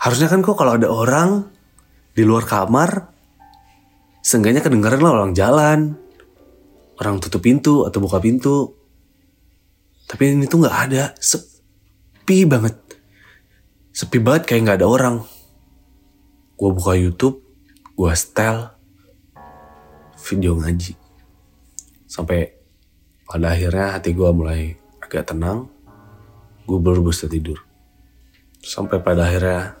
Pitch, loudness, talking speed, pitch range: 95 Hz, -17 LUFS, 110 wpm, 85-115 Hz